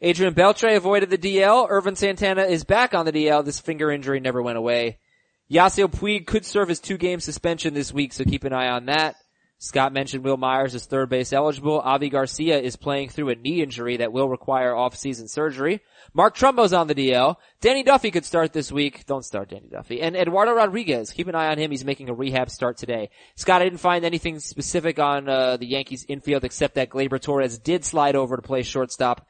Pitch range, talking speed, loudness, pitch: 130-175 Hz, 215 wpm, -22 LUFS, 145 Hz